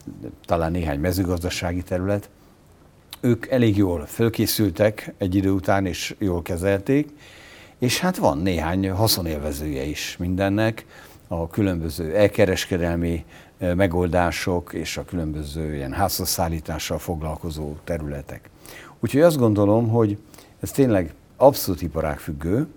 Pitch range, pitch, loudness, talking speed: 85-105 Hz, 90 Hz, -23 LUFS, 105 wpm